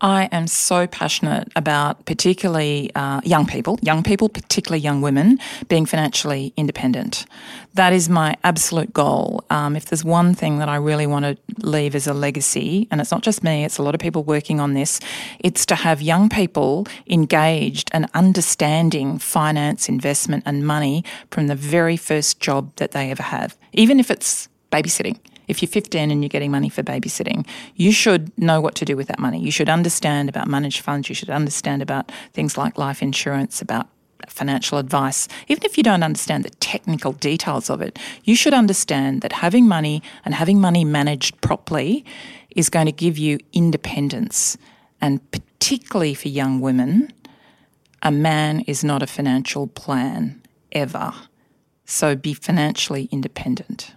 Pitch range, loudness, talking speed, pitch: 145-190 Hz, -19 LUFS, 170 wpm, 160 Hz